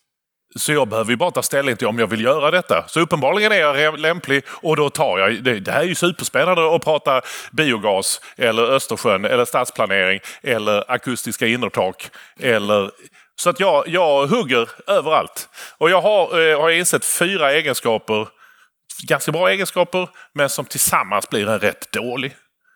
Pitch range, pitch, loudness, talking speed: 125-175 Hz, 150 Hz, -18 LUFS, 165 wpm